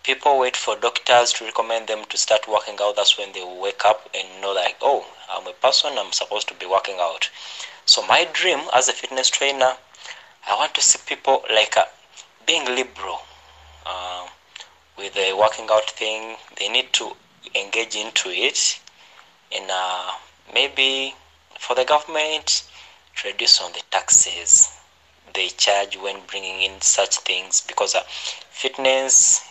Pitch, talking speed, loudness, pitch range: 110 Hz, 155 wpm, -19 LUFS, 100-130 Hz